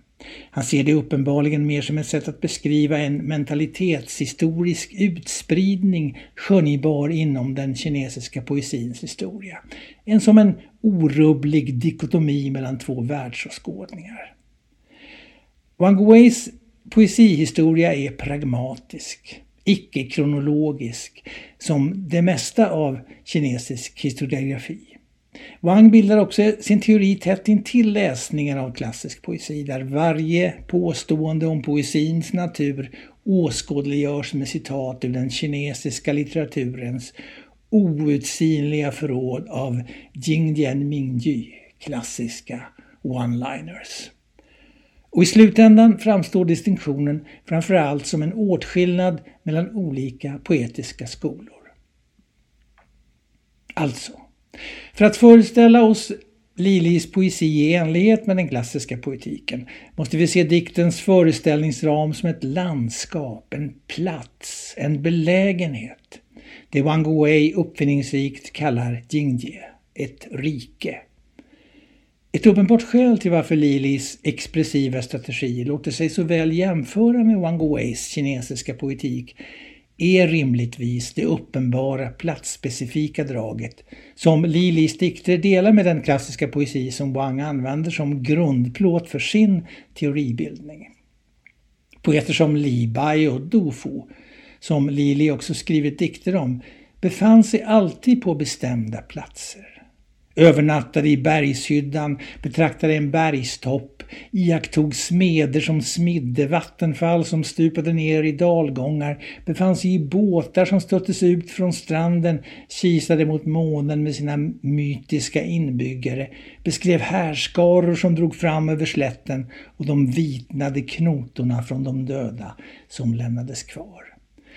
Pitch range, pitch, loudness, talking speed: 140-175 Hz, 155 Hz, -20 LUFS, 110 wpm